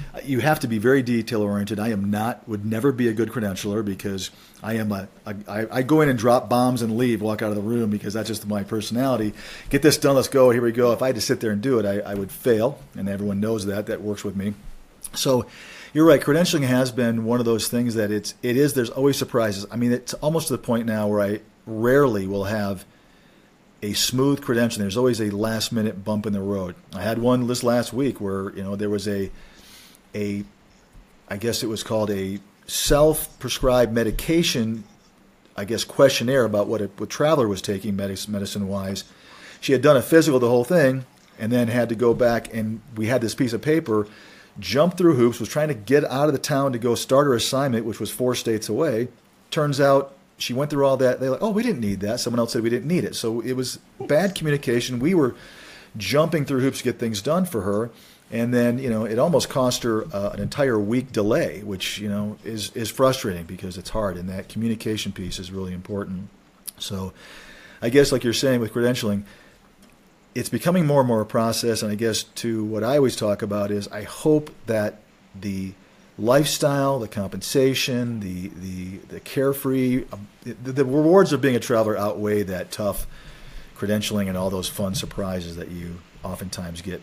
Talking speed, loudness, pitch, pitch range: 210 wpm, -22 LUFS, 115 Hz, 105-130 Hz